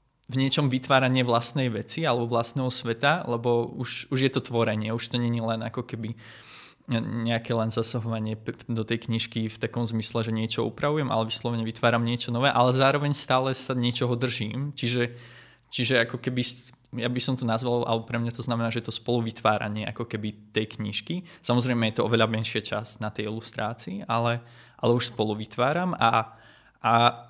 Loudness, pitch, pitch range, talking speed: -27 LUFS, 120 Hz, 115-125 Hz, 180 wpm